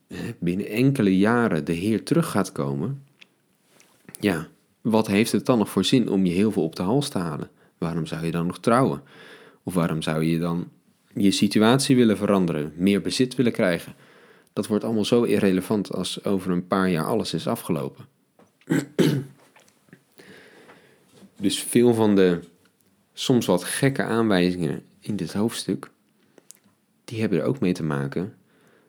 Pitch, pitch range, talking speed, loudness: 100 Hz, 85-115 Hz, 155 wpm, -23 LUFS